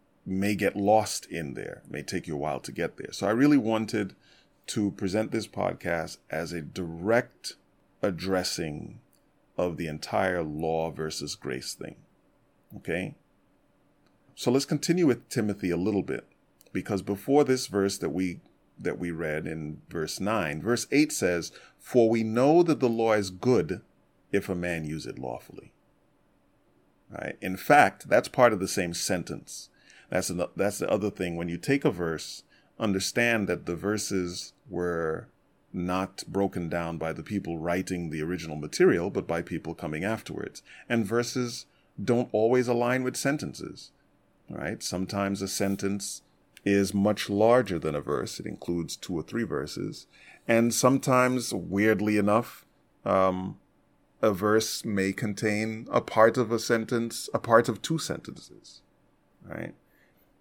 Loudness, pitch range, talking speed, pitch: -28 LUFS, 90-115 Hz, 155 wpm, 100 Hz